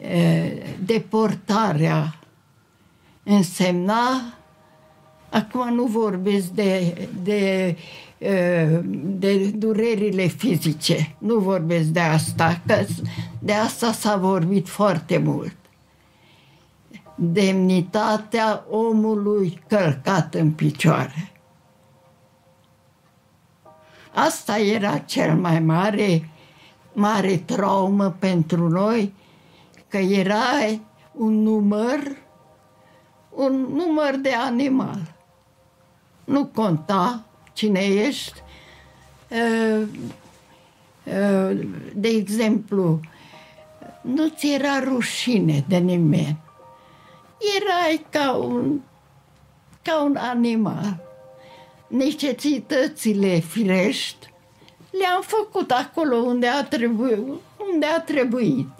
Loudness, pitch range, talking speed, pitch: -21 LUFS, 170-235 Hz, 75 wpm, 200 Hz